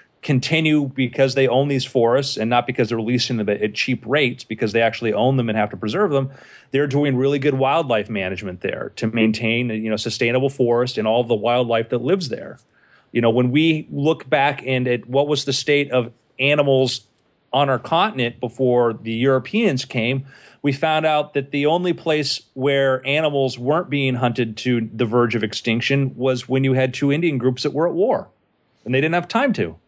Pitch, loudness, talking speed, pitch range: 130 Hz, -20 LUFS, 200 wpm, 120-145 Hz